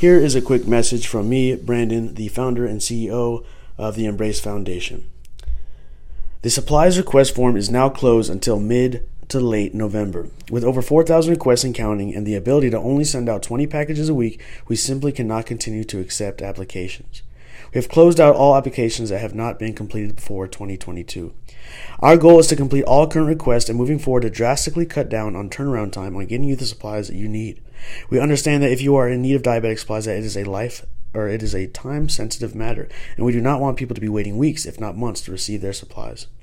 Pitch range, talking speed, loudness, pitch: 105-130 Hz, 220 wpm, -19 LUFS, 115 Hz